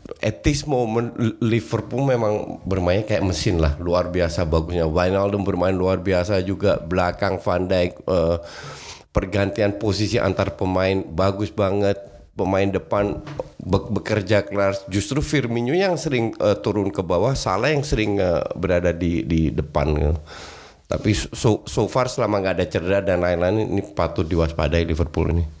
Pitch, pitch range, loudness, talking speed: 95 Hz, 90-105 Hz, -21 LUFS, 150 wpm